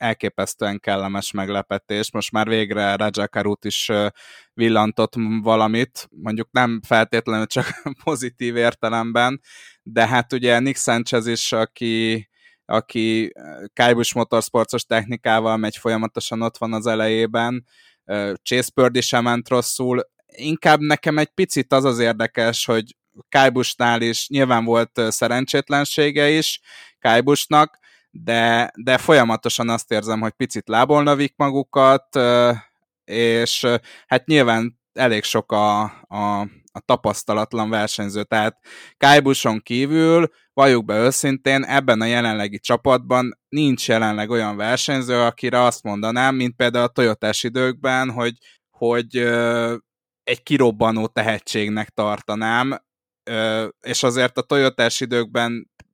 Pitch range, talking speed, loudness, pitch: 110-130 Hz, 115 wpm, -19 LUFS, 120 Hz